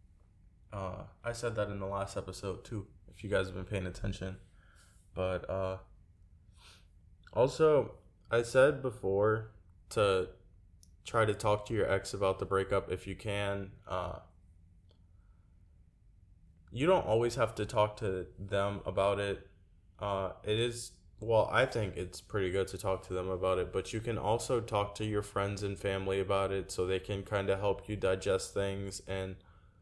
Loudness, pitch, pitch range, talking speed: -34 LUFS, 95 Hz, 90-105 Hz, 165 wpm